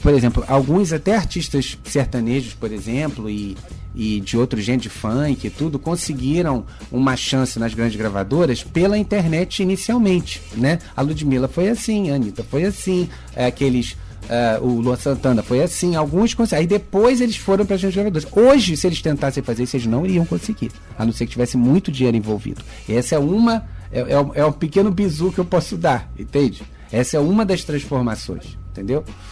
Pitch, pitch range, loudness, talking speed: 140 Hz, 120-180 Hz, -19 LUFS, 185 wpm